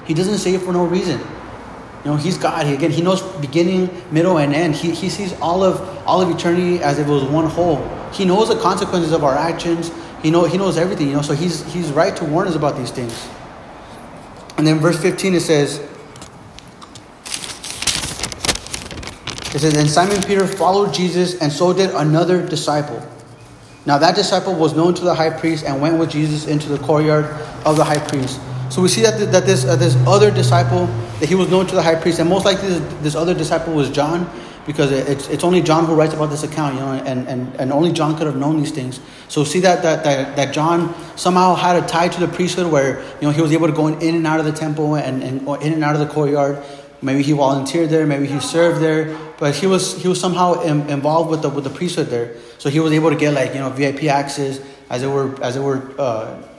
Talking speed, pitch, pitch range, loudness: 240 wpm, 155 Hz, 145-175 Hz, -17 LUFS